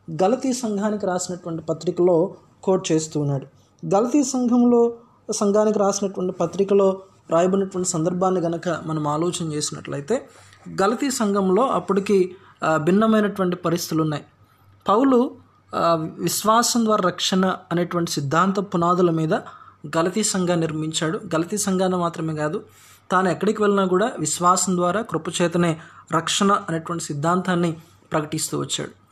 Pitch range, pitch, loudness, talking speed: 160-200 Hz, 180 Hz, -21 LUFS, 105 wpm